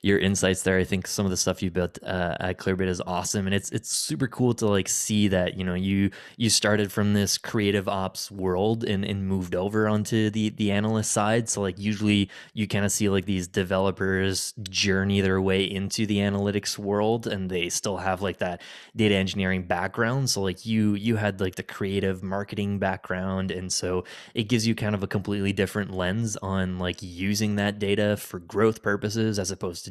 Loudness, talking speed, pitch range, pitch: -26 LUFS, 205 wpm, 95-105 Hz, 100 Hz